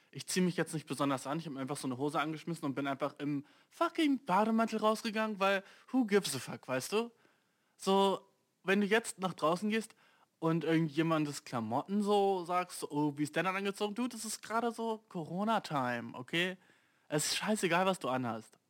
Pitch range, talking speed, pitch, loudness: 145-210 Hz, 195 wpm, 180 Hz, -34 LUFS